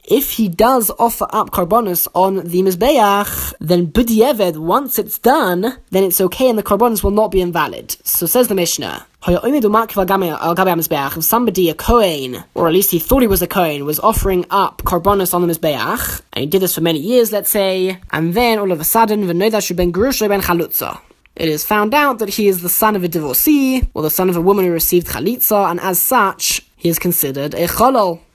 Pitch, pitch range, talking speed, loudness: 190 Hz, 175-215 Hz, 195 wpm, -15 LUFS